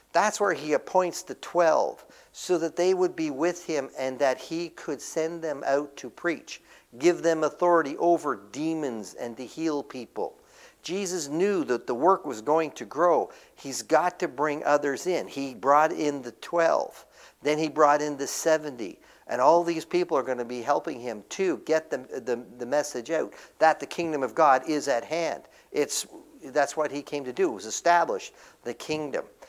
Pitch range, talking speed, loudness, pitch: 145-175 Hz, 190 wpm, -27 LUFS, 155 Hz